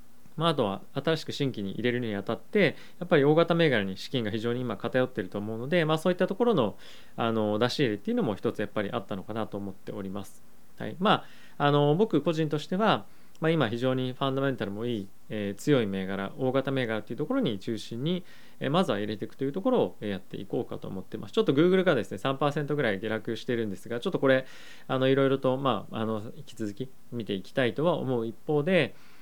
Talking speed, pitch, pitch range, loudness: 460 characters per minute, 125 Hz, 110-150 Hz, -28 LUFS